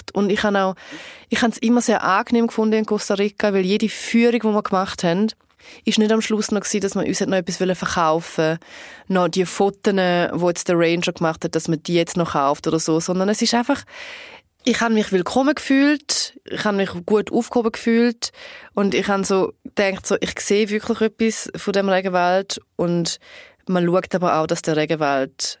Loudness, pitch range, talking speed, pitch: -20 LUFS, 175-225 Hz, 195 wpm, 200 Hz